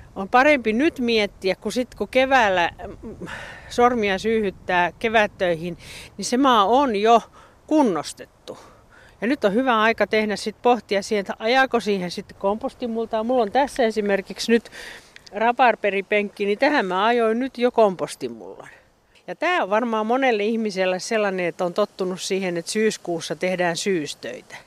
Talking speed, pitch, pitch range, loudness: 145 wpm, 220 Hz, 195-240 Hz, -21 LUFS